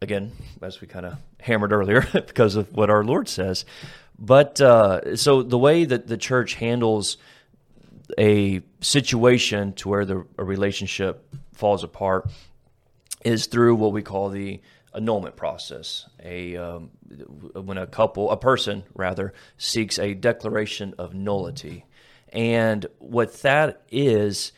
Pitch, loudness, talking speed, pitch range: 105 Hz, -21 LUFS, 135 wpm, 95-115 Hz